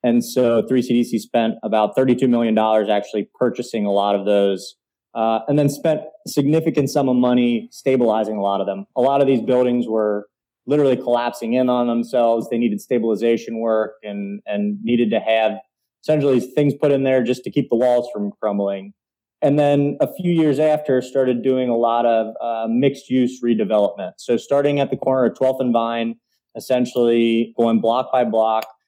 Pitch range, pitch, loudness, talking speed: 110-130 Hz, 120 Hz, -19 LUFS, 180 wpm